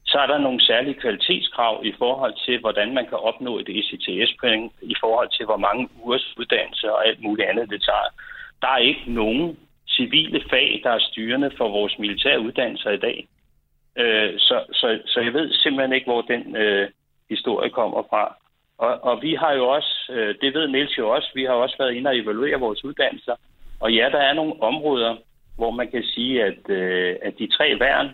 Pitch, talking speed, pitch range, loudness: 115 Hz, 200 wpm, 105-130 Hz, -21 LUFS